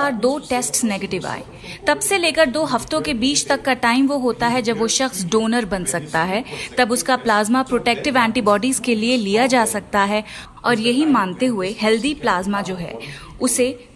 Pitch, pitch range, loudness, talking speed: 240 Hz, 210-260 Hz, -18 LUFS, 190 wpm